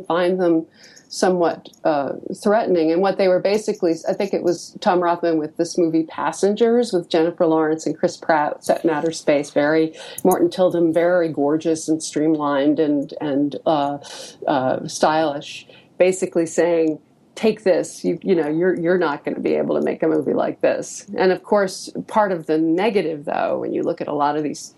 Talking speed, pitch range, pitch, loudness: 185 wpm, 160-185 Hz, 170 Hz, -20 LUFS